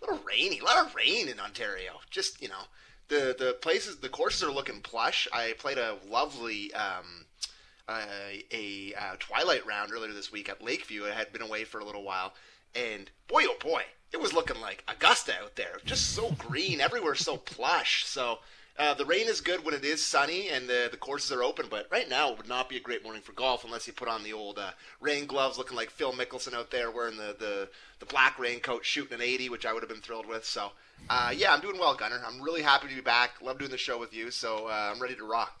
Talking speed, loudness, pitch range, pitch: 245 wpm, -30 LUFS, 110-160 Hz, 125 Hz